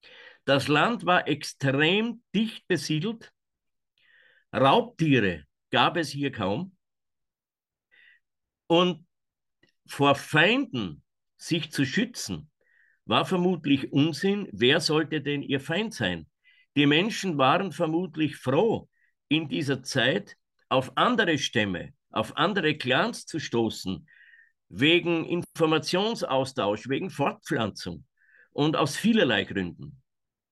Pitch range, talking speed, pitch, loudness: 135-185 Hz, 100 wpm, 155 Hz, -26 LUFS